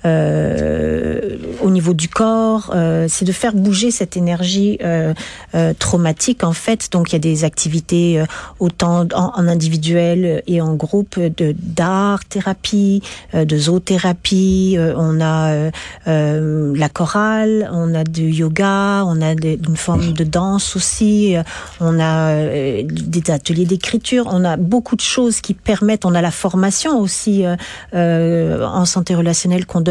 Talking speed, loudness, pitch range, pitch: 160 wpm, -16 LUFS, 160-195 Hz, 175 Hz